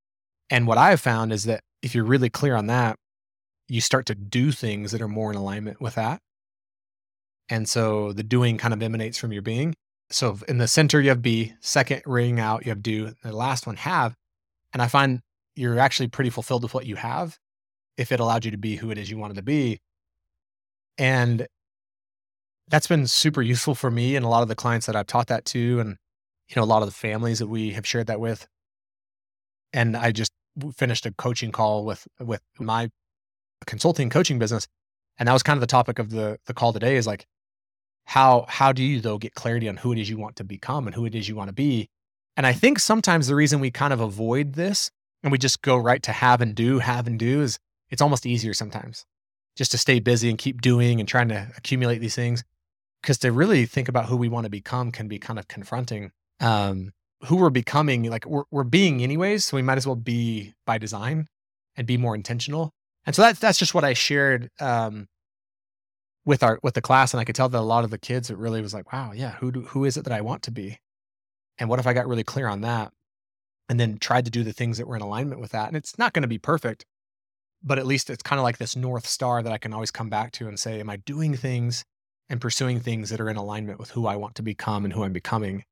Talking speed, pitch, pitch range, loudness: 240 wpm, 115 Hz, 110-130 Hz, -24 LUFS